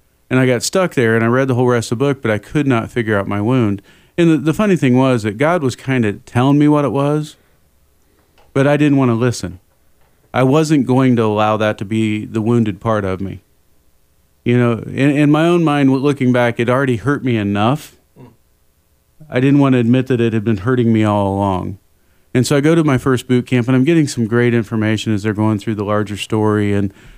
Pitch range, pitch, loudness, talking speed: 105-130 Hz, 120 Hz, -15 LUFS, 235 wpm